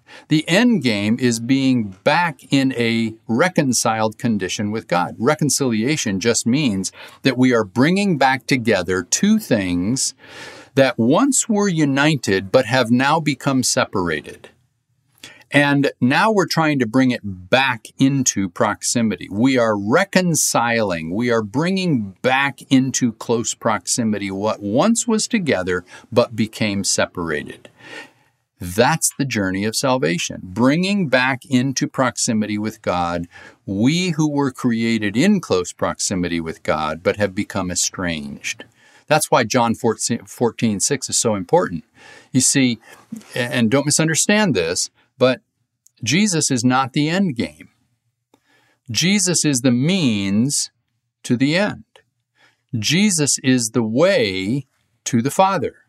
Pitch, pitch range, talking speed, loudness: 125 Hz, 110-145 Hz, 130 wpm, -18 LUFS